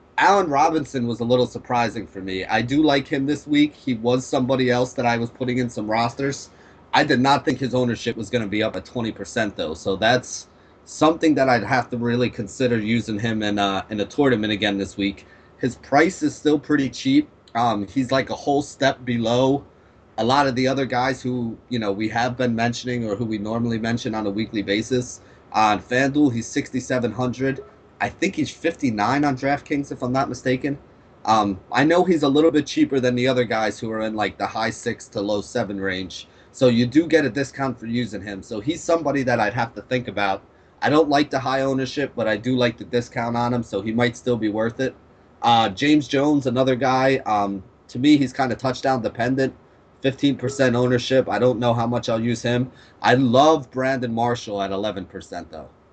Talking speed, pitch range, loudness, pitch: 215 wpm, 110-135 Hz, -21 LUFS, 125 Hz